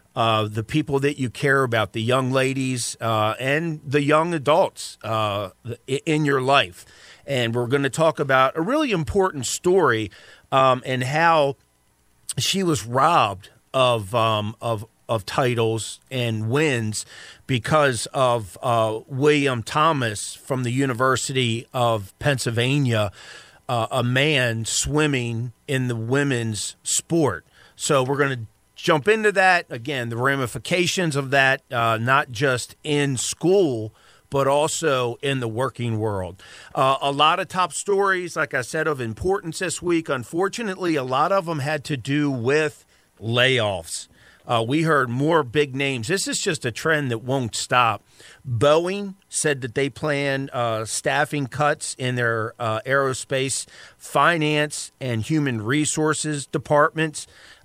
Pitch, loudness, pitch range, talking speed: 135 Hz, -22 LUFS, 115-150 Hz, 145 wpm